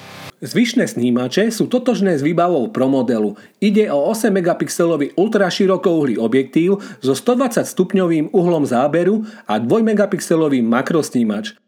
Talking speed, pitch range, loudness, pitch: 120 wpm, 150-215 Hz, -17 LUFS, 185 Hz